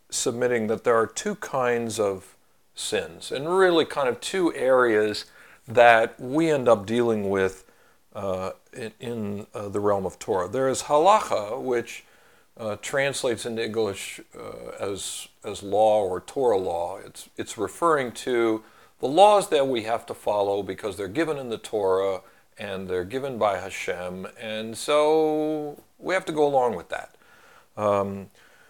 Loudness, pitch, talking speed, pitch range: -24 LUFS, 115 Hz, 155 wpm, 100-145 Hz